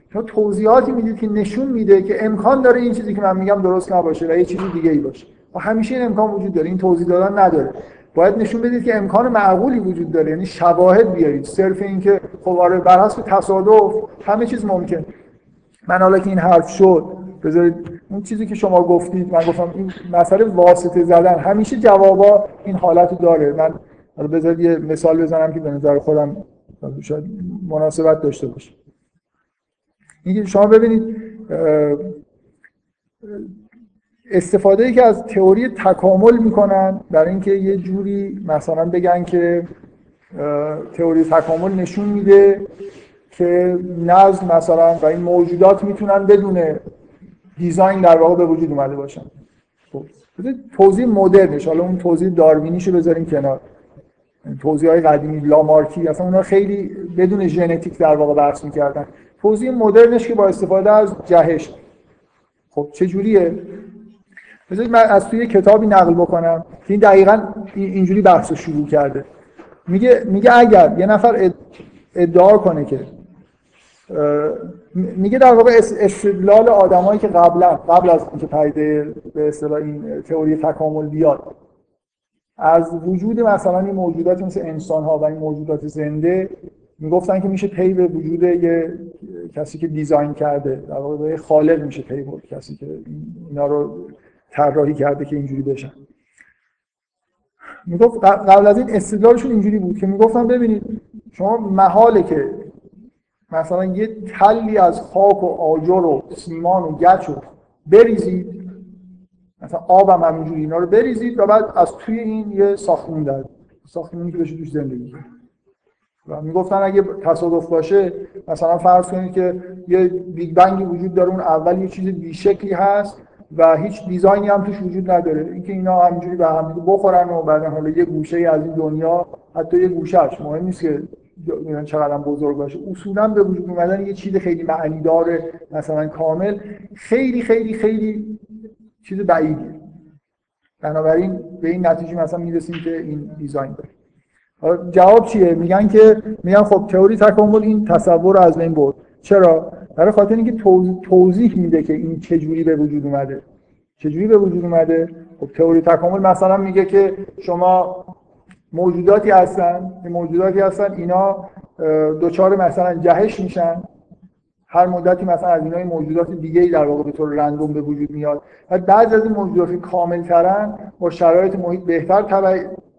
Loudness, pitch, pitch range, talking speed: -15 LUFS, 180 Hz, 165-200 Hz, 150 wpm